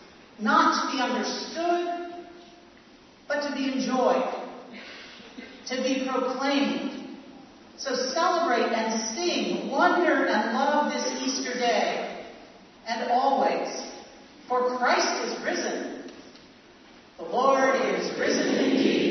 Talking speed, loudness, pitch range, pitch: 100 wpm, -26 LUFS, 250-290 Hz, 270 Hz